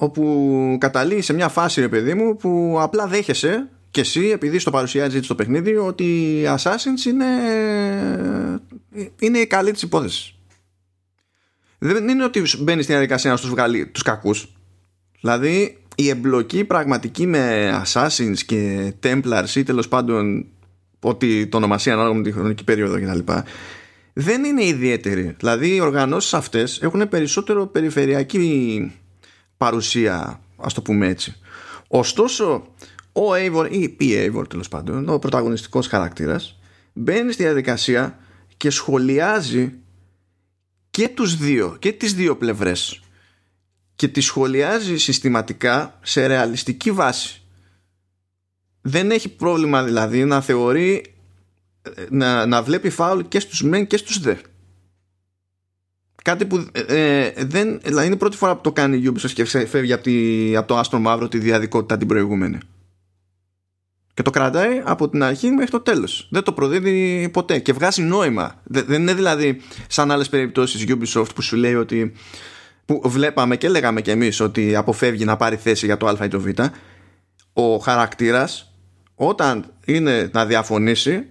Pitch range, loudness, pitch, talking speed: 100-155 Hz, -19 LUFS, 125 Hz, 145 wpm